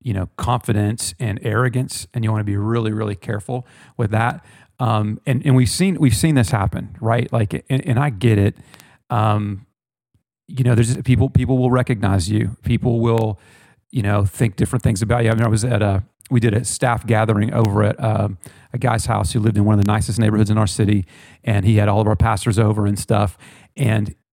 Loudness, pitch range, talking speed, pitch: -19 LUFS, 105-125 Hz, 215 wpm, 115 Hz